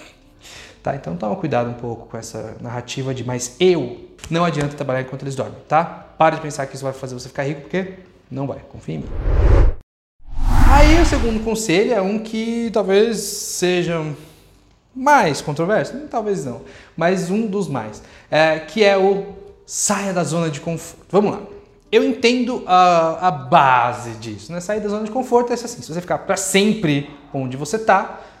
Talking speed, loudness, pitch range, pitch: 180 wpm, -19 LUFS, 135-205 Hz, 165 Hz